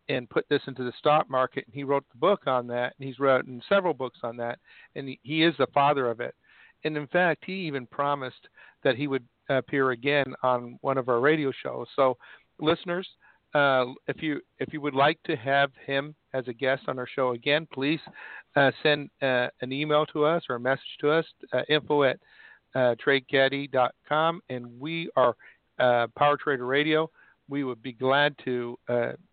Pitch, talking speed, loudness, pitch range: 140 Hz, 195 wpm, -27 LUFS, 130-150 Hz